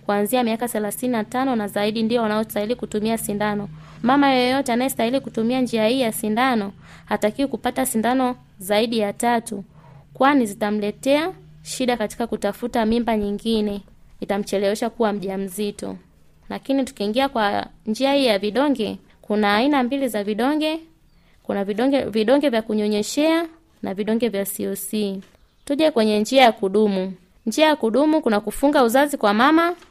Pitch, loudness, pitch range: 225 Hz, -21 LUFS, 205-260 Hz